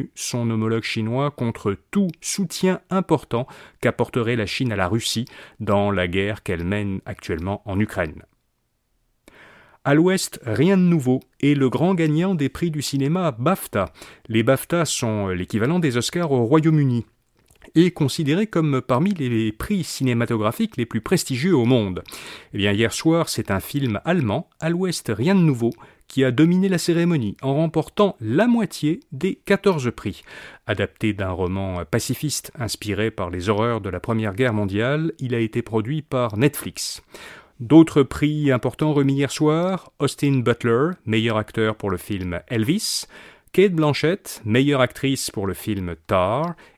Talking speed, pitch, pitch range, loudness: 155 wpm, 130 Hz, 110-160 Hz, -21 LUFS